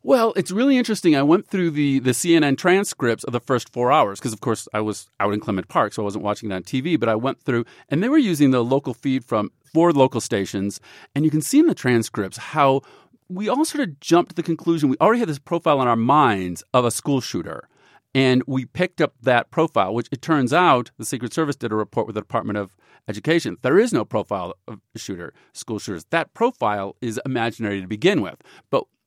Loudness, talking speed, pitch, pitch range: -21 LUFS, 235 wpm, 130 Hz, 110-165 Hz